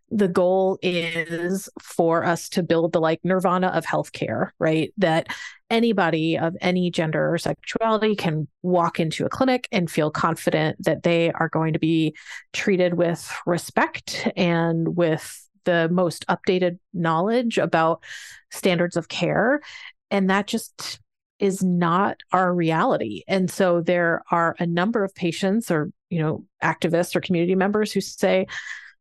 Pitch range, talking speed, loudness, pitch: 165-190 Hz, 145 wpm, -22 LUFS, 175 Hz